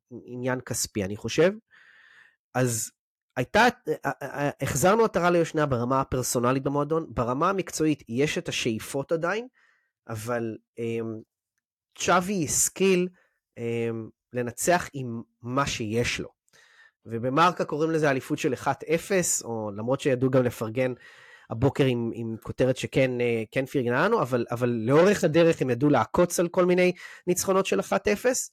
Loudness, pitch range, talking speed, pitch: -25 LUFS, 120-170 Hz, 125 wpm, 135 Hz